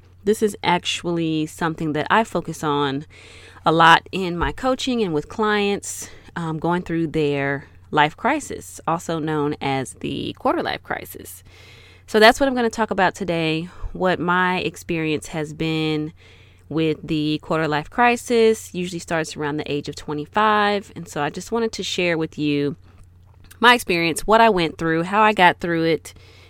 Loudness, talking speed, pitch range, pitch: -20 LUFS, 170 wpm, 145-185 Hz, 160 Hz